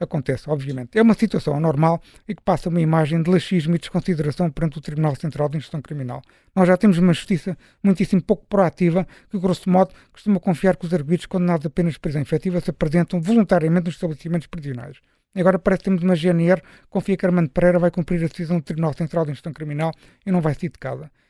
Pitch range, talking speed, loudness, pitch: 160-185 Hz, 215 wpm, -21 LUFS, 175 Hz